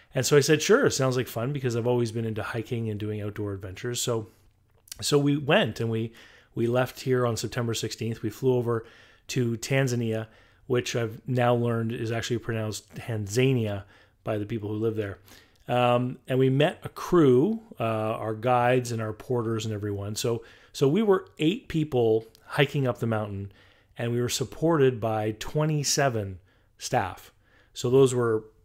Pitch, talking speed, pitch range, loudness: 115 Hz, 175 wpm, 110-130 Hz, -26 LUFS